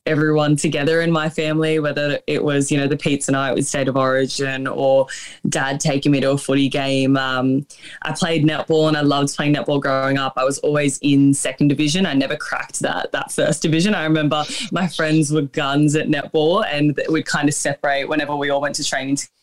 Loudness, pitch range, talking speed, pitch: -18 LUFS, 140-155 Hz, 215 wpm, 145 Hz